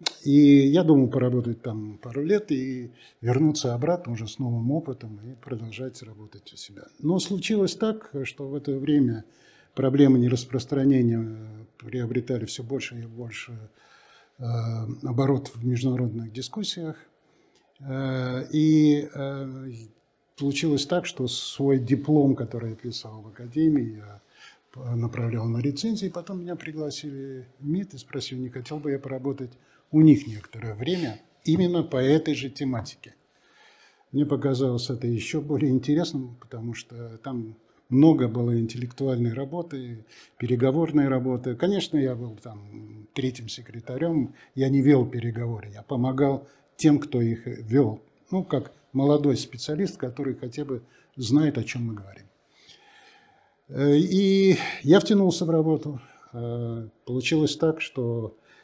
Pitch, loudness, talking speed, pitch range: 135 Hz, -25 LUFS, 125 wpm, 120-150 Hz